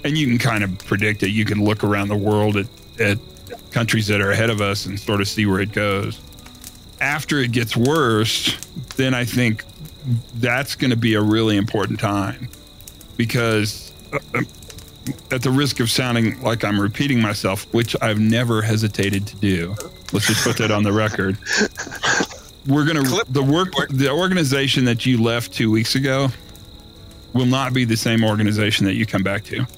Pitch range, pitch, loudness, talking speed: 105-125 Hz, 110 Hz, -19 LUFS, 180 wpm